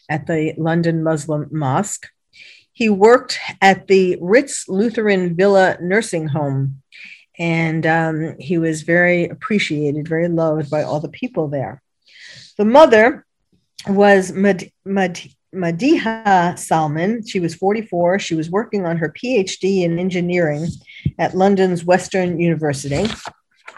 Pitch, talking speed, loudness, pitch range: 175 Hz, 125 wpm, -17 LUFS, 160-195 Hz